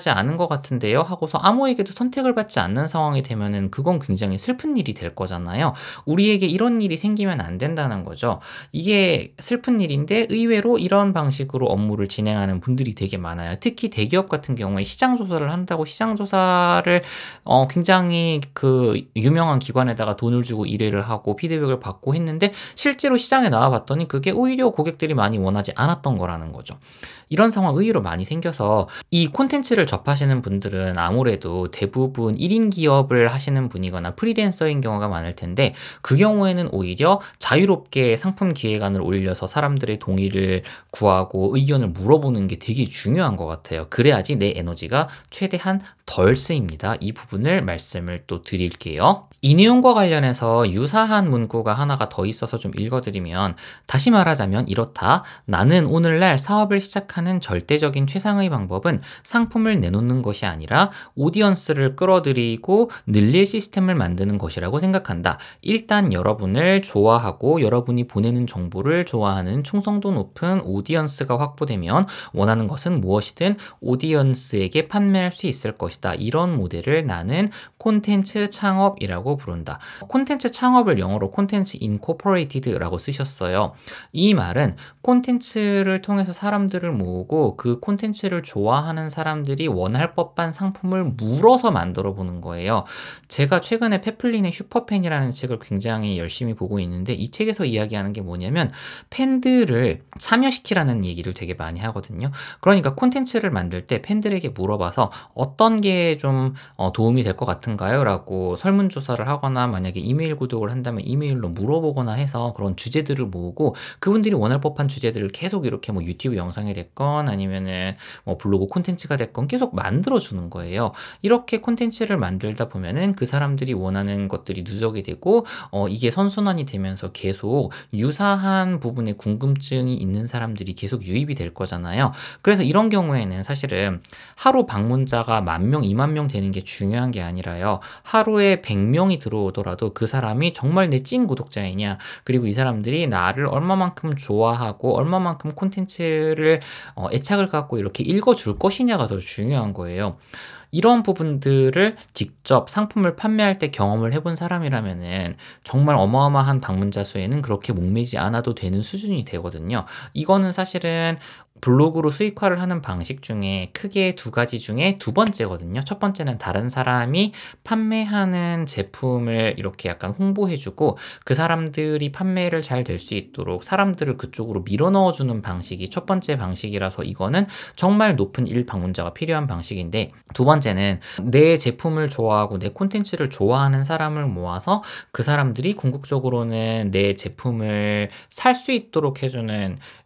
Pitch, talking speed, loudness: 135 Hz, 360 characters per minute, -21 LUFS